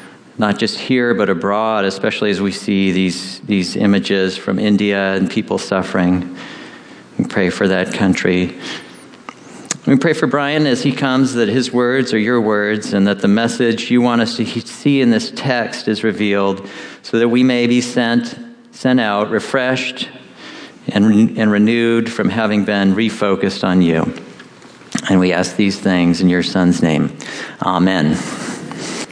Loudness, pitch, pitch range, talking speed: -16 LUFS, 105 Hz, 95-120 Hz, 160 wpm